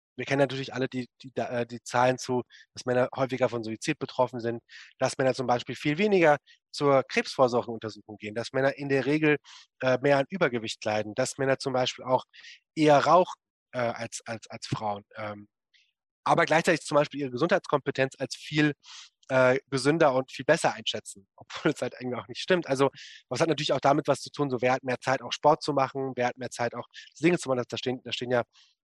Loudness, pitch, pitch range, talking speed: -27 LUFS, 130 Hz, 120-140 Hz, 210 wpm